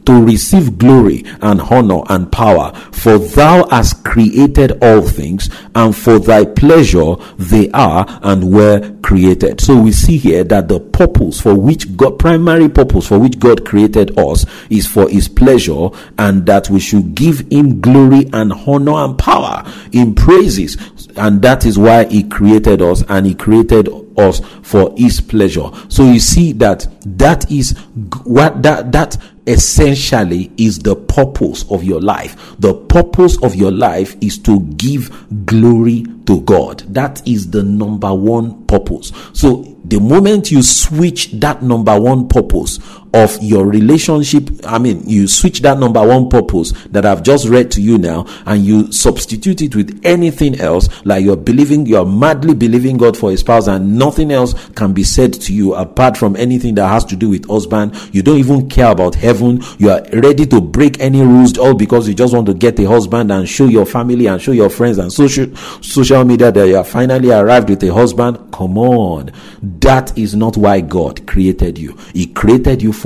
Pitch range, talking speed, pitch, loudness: 100-130 Hz, 180 wpm, 115 Hz, -10 LUFS